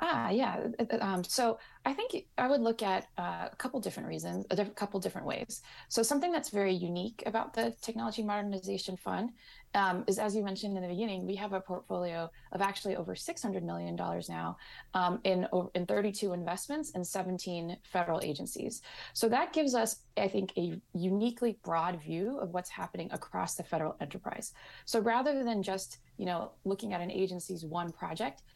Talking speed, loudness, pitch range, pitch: 185 wpm, -35 LUFS, 180-225 Hz, 195 Hz